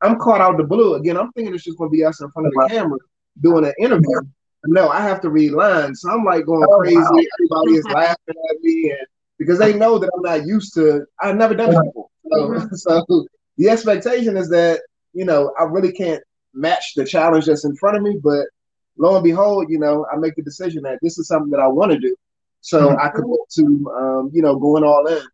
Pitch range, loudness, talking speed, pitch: 155-210 Hz, -16 LUFS, 240 wpm, 165 Hz